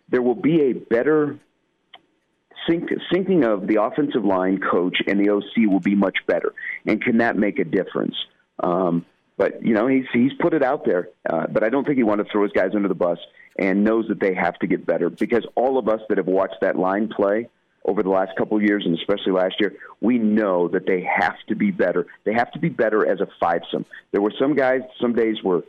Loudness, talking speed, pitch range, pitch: -21 LUFS, 235 wpm, 95-125 Hz, 105 Hz